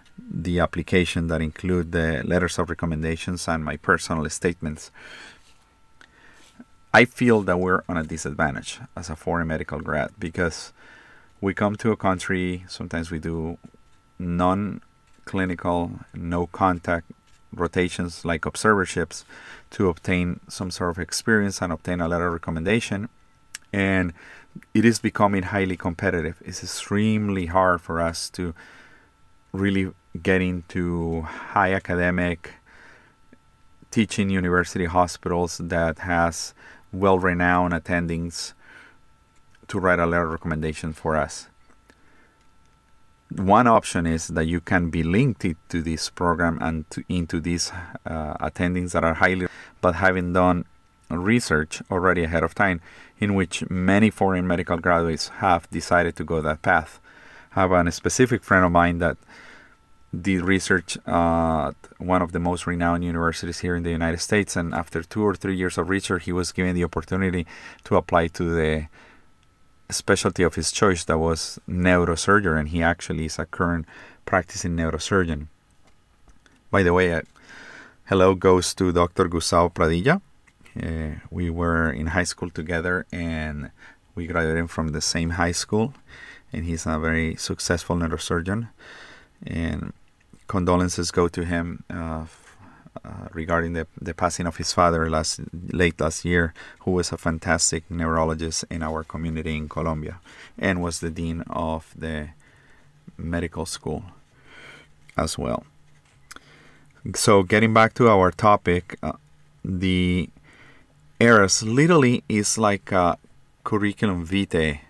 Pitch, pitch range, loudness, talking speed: 85 Hz, 80-95 Hz, -23 LUFS, 135 wpm